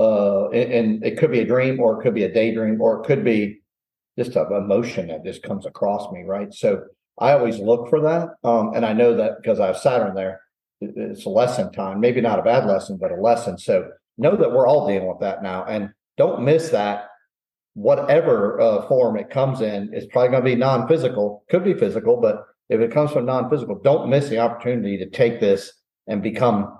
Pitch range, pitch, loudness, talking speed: 105-135 Hz, 115 Hz, -20 LUFS, 215 wpm